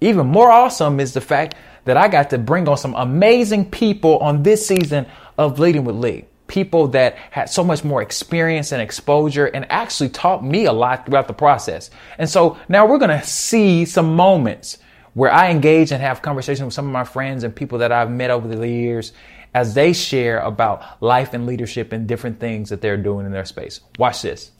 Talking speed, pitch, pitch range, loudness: 210 wpm, 140 Hz, 120-170 Hz, -16 LUFS